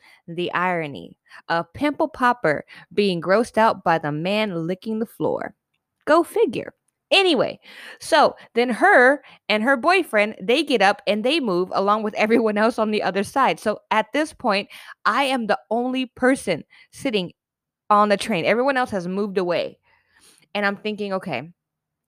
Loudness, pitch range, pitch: -21 LUFS, 195-250 Hz, 215 Hz